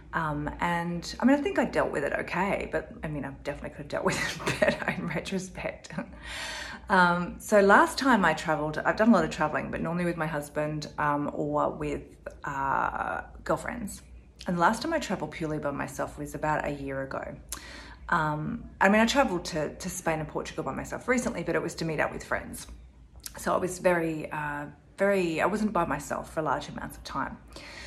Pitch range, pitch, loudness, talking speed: 150-195 Hz, 165 Hz, -28 LUFS, 205 wpm